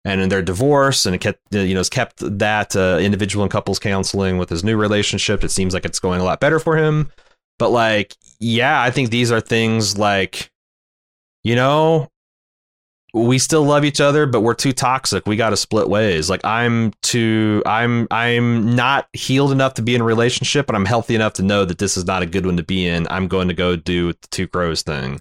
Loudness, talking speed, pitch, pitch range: -17 LUFS, 225 wpm, 105 Hz, 95-120 Hz